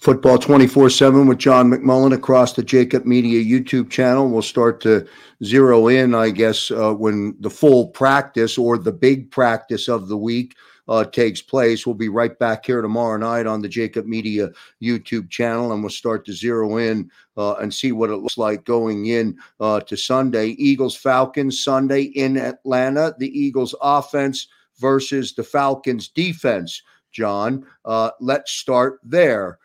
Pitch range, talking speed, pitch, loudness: 110-135 Hz, 165 wpm, 120 Hz, -18 LUFS